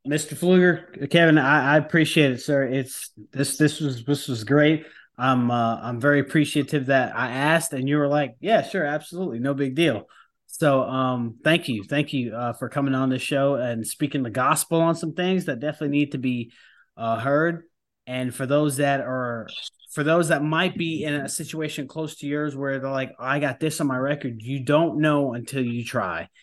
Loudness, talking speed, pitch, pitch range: -23 LUFS, 205 wpm, 145 Hz, 130-155 Hz